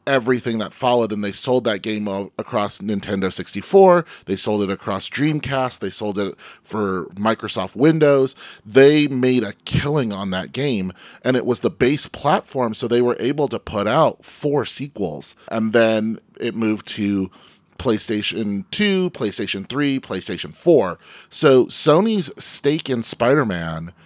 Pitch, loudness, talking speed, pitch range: 115 Hz, -20 LUFS, 150 wpm, 100-135 Hz